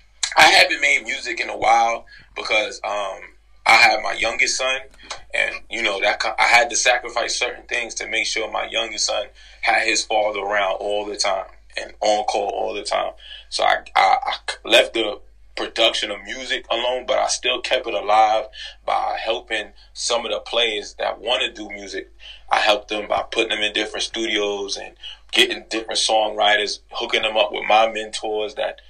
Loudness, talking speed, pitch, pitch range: -19 LUFS, 185 wpm, 110 Hz, 105-115 Hz